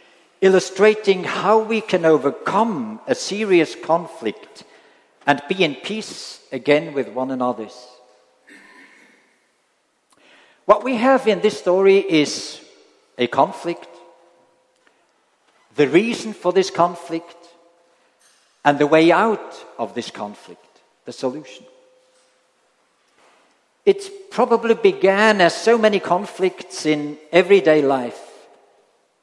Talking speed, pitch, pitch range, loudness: 100 wpm, 180 Hz, 155-215 Hz, -18 LUFS